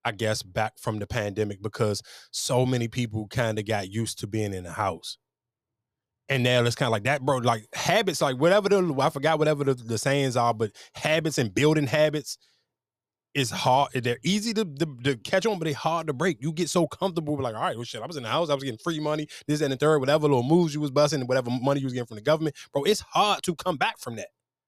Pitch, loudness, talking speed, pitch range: 135 Hz, -26 LUFS, 255 wpm, 115-155 Hz